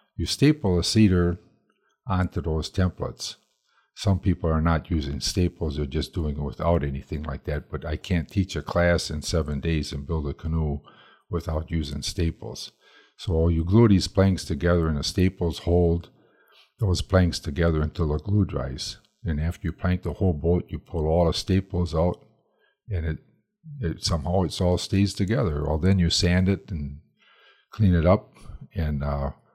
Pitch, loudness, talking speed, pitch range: 85 Hz, -25 LUFS, 175 wpm, 80-95 Hz